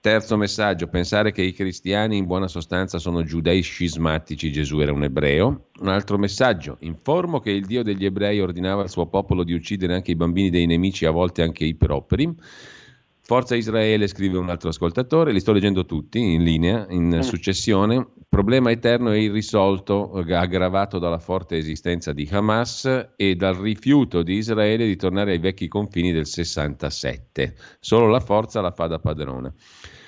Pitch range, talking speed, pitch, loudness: 85-105 Hz, 170 wpm, 95 Hz, -21 LUFS